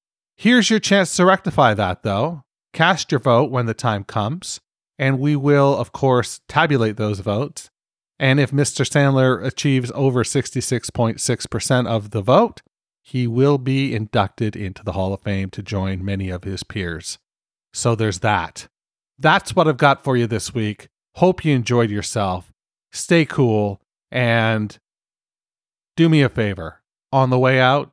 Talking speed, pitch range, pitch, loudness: 155 wpm, 105-140 Hz, 125 Hz, -19 LUFS